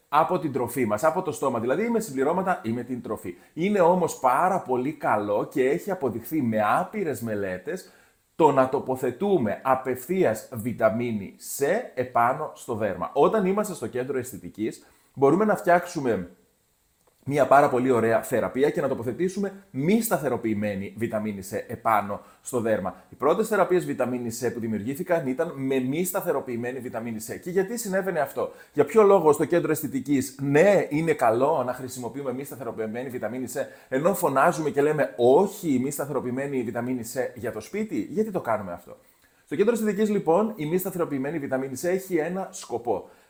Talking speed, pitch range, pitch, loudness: 165 wpm, 120-185 Hz, 140 Hz, -25 LUFS